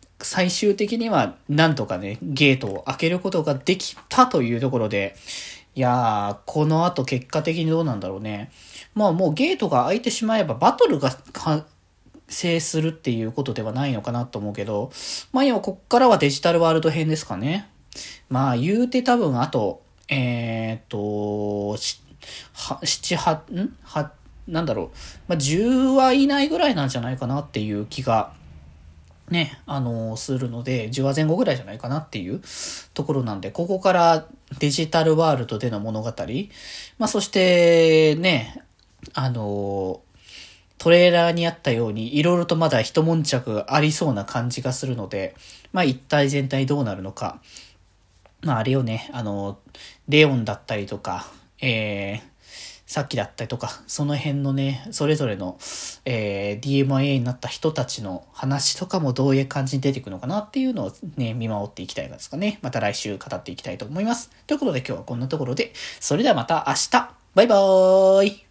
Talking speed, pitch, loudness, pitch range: 340 characters per minute, 135 Hz, -22 LUFS, 110-165 Hz